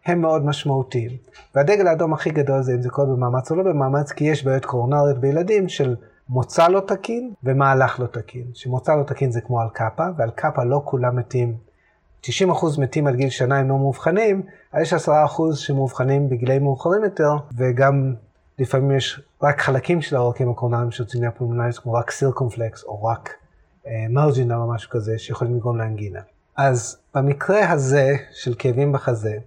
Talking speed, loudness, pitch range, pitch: 170 wpm, -20 LUFS, 120-150 Hz, 135 Hz